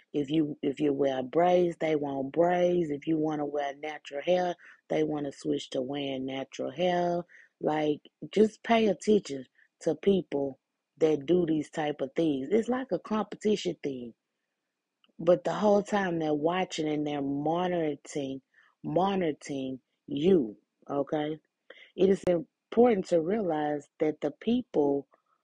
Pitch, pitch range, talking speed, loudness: 155 Hz, 145-180 Hz, 145 wpm, -29 LUFS